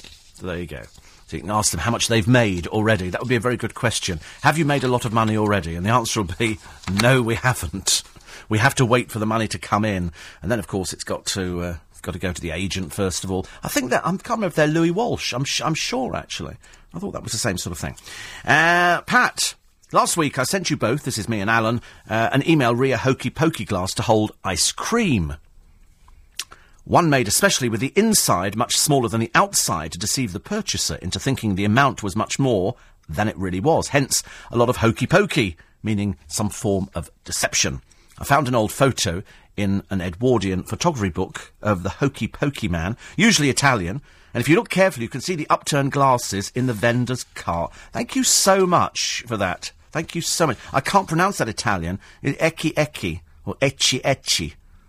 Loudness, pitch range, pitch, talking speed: -21 LUFS, 95-140 Hz, 115 Hz, 220 wpm